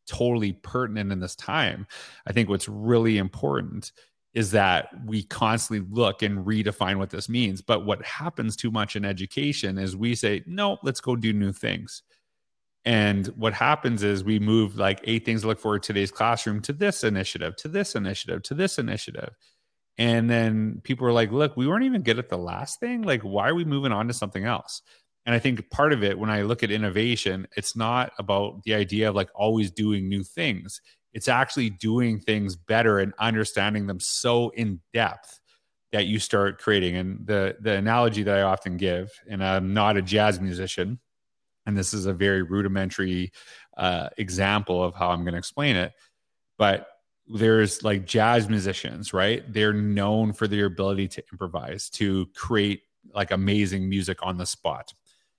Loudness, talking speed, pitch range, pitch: -25 LUFS, 185 wpm, 100-115 Hz, 105 Hz